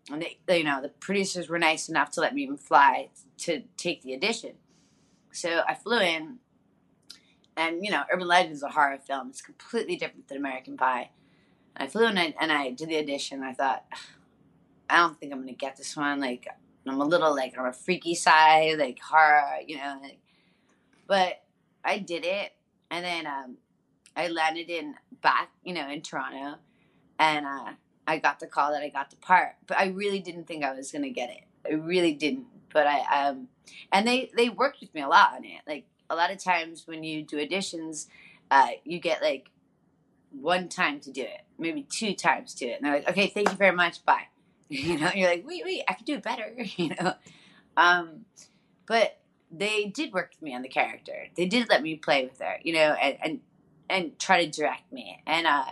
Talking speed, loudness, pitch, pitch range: 220 wpm, -26 LUFS, 170 Hz, 145-205 Hz